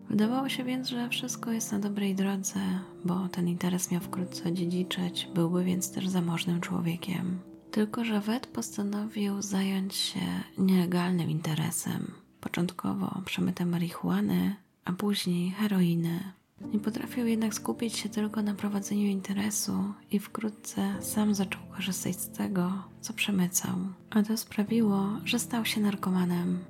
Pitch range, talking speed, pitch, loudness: 180-210 Hz, 135 wpm, 195 Hz, -30 LUFS